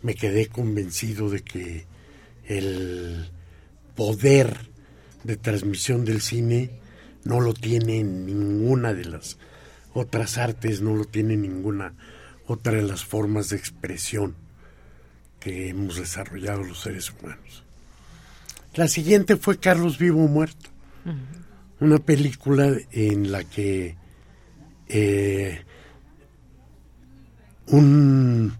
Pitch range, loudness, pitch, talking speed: 90-120 Hz, -23 LUFS, 105 Hz, 105 wpm